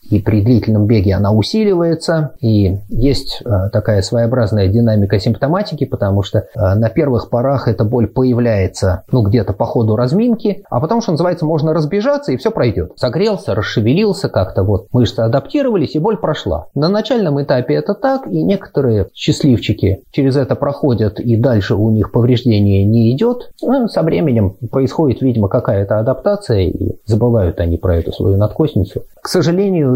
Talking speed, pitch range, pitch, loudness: 155 wpm, 105-155 Hz, 120 Hz, -14 LUFS